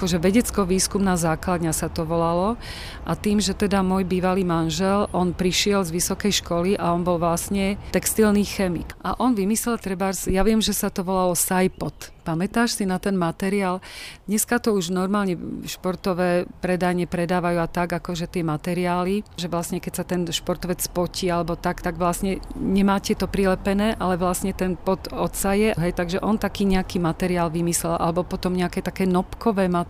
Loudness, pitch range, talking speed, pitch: -23 LUFS, 175-195 Hz, 175 wpm, 185 Hz